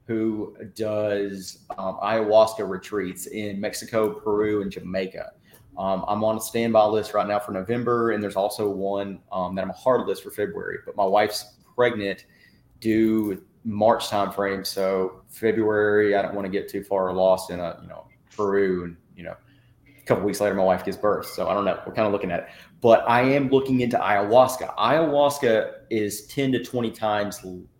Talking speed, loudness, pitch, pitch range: 190 wpm, -24 LUFS, 105 Hz, 100-115 Hz